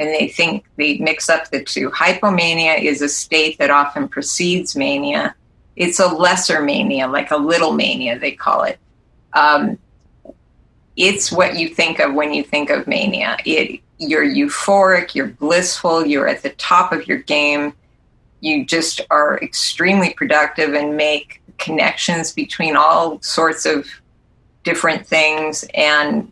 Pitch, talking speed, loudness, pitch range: 170 Hz, 150 wpm, -16 LUFS, 150-255 Hz